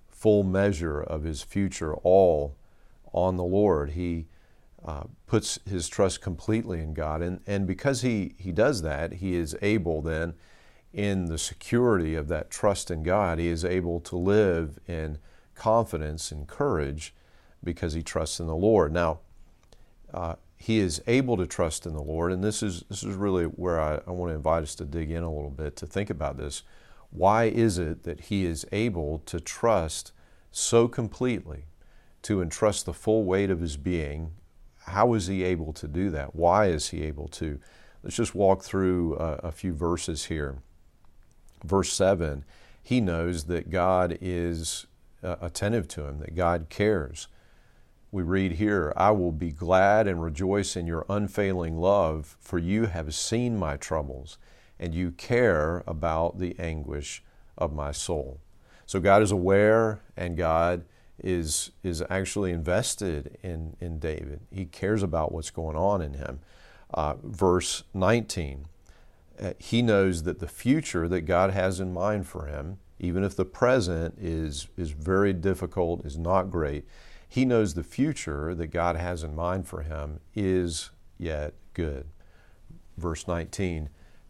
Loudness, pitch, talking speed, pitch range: -27 LUFS, 85 Hz, 165 wpm, 80-95 Hz